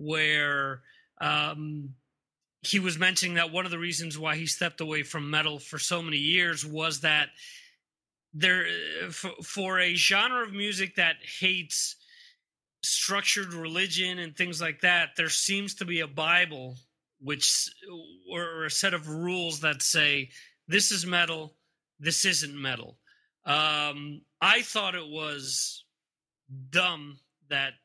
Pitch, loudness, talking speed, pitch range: 165 Hz, -26 LUFS, 140 wpm, 150-185 Hz